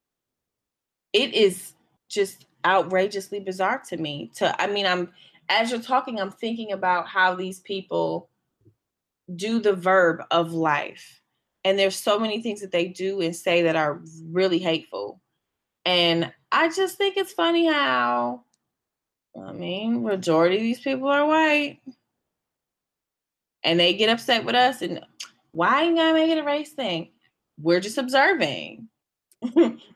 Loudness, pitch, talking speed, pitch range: -23 LUFS, 195 Hz, 140 wpm, 175-250 Hz